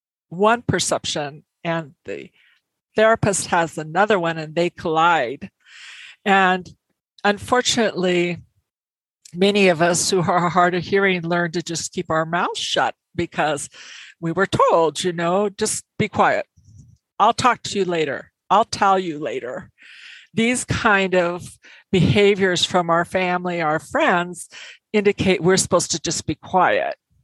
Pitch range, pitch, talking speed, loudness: 165-195 Hz, 180 Hz, 135 wpm, -19 LUFS